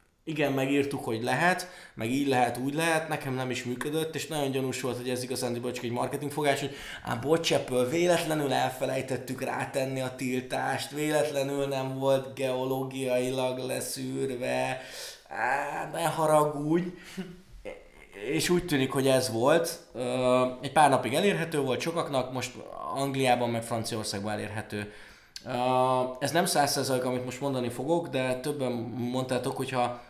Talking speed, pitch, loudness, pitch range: 135 wpm, 130 Hz, -29 LUFS, 125-150 Hz